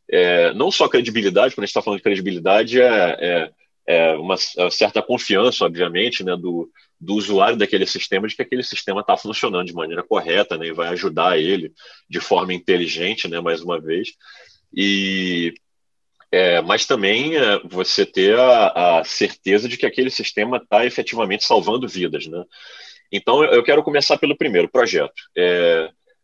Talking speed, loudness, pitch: 165 wpm, -18 LUFS, 100 Hz